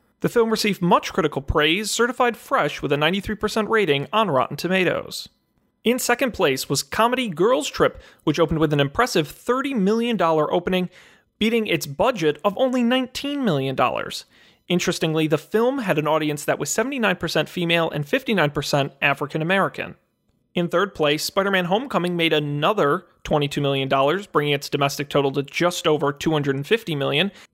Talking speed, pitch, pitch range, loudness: 155 wpm, 175 Hz, 150-215 Hz, -21 LUFS